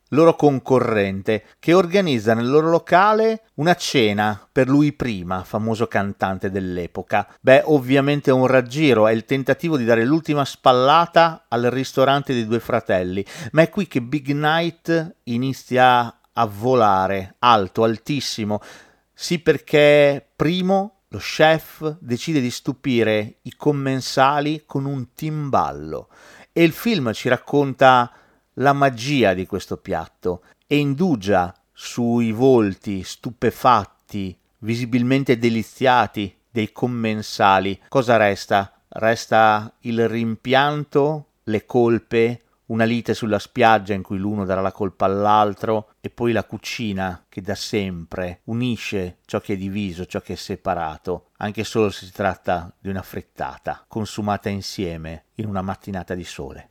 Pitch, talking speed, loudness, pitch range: 115 Hz, 130 wpm, -20 LUFS, 100-140 Hz